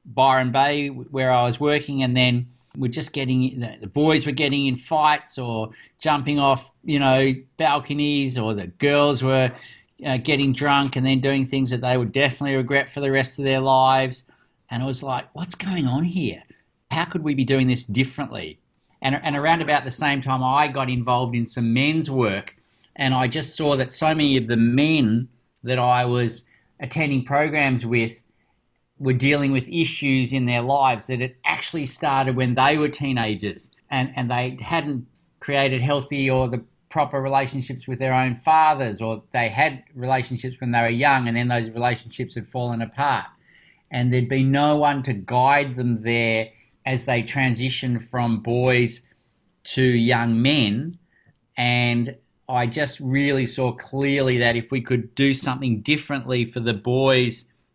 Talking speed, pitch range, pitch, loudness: 175 wpm, 125-140 Hz, 130 Hz, -21 LUFS